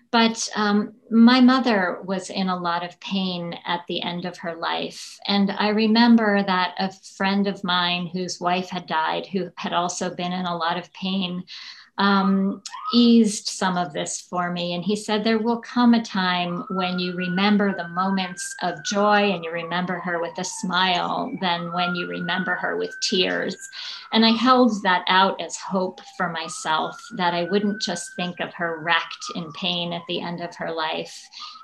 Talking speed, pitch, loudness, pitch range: 185 wpm, 190 Hz, -22 LUFS, 175-210 Hz